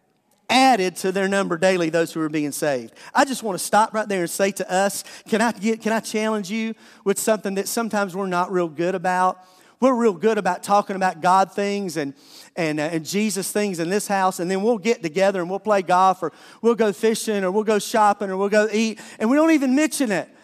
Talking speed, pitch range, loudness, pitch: 240 wpm, 185-220 Hz, -21 LUFS, 200 Hz